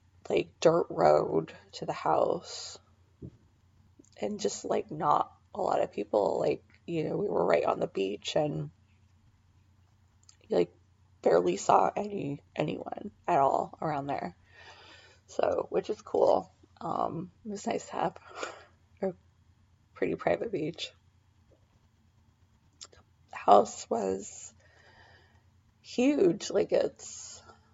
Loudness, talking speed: -30 LUFS, 115 wpm